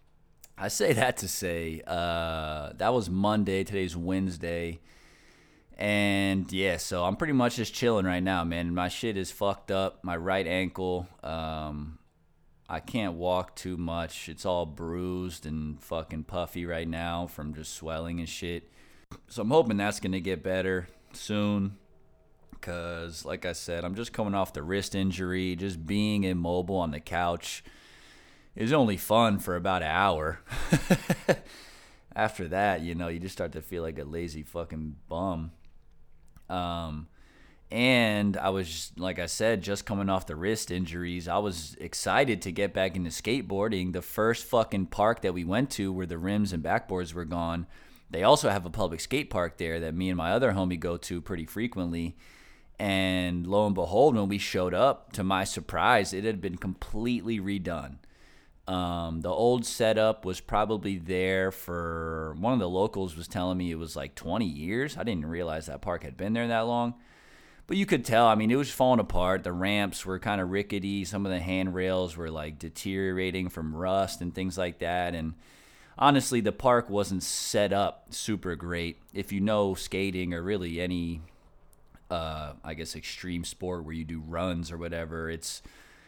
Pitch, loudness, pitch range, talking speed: 90 Hz, -30 LUFS, 85-100 Hz, 175 wpm